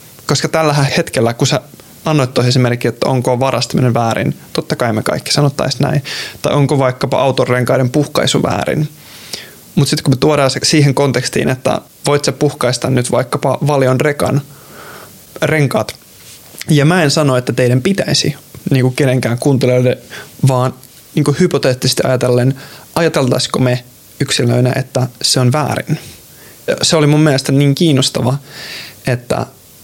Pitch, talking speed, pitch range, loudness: 135 Hz, 135 wpm, 125-150 Hz, -14 LUFS